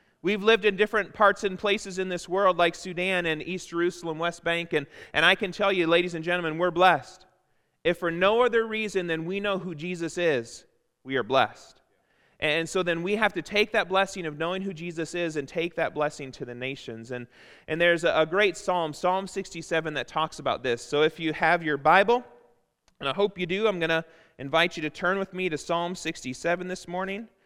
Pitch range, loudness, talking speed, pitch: 160-190 Hz, -26 LUFS, 220 wpm, 175 Hz